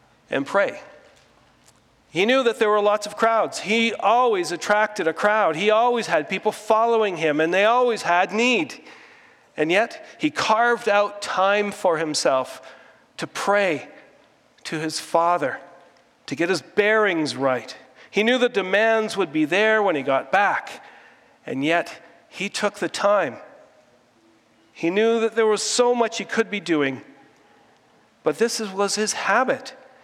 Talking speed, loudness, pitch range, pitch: 155 wpm, -21 LUFS, 175-230 Hz, 210 Hz